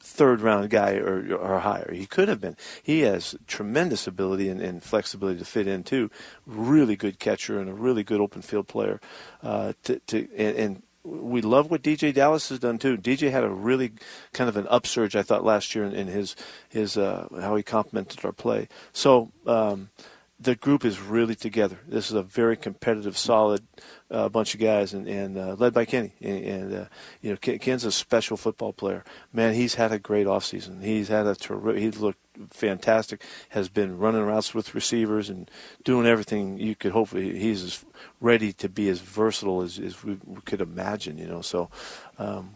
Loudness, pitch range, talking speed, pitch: -26 LUFS, 100-115 Hz, 195 wpm, 110 Hz